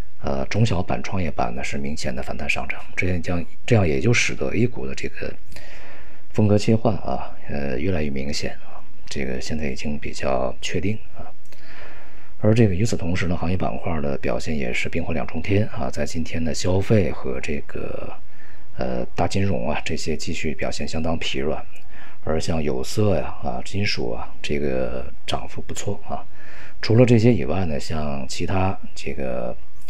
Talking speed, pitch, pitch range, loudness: 255 characters per minute, 85 Hz, 75-100 Hz, -24 LUFS